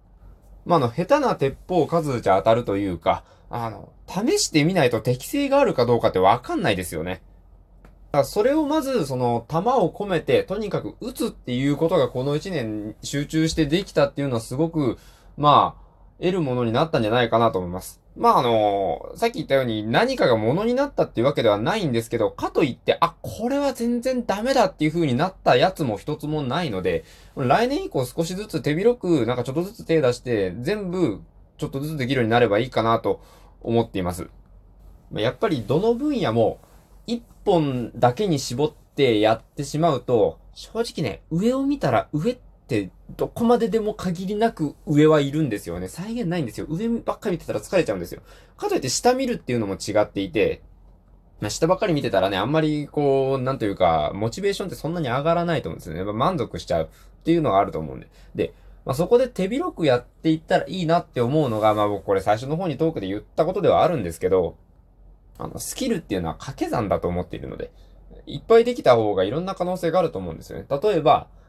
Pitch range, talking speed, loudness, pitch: 115-190 Hz, 435 characters per minute, -22 LUFS, 150 Hz